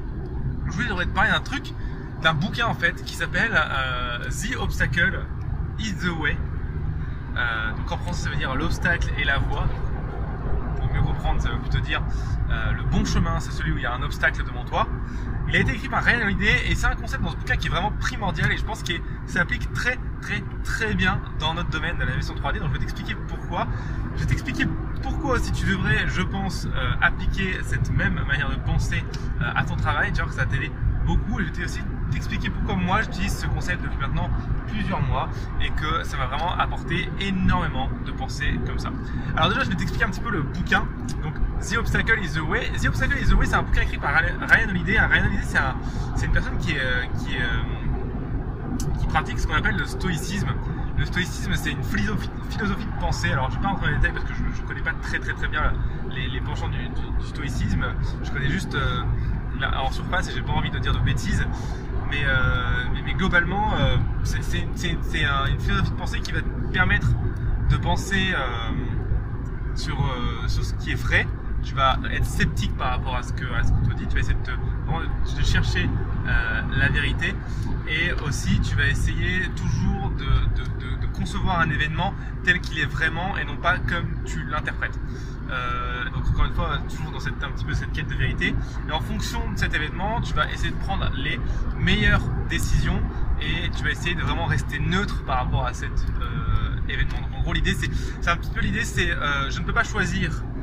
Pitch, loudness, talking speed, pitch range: 125 Hz, -25 LUFS, 220 wpm, 115-130 Hz